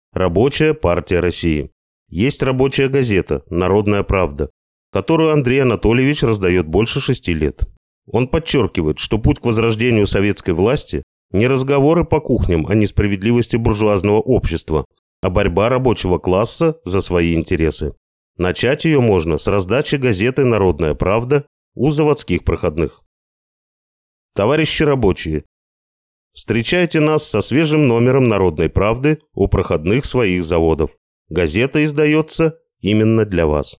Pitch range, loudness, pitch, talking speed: 90-135 Hz, -16 LUFS, 110 Hz, 120 wpm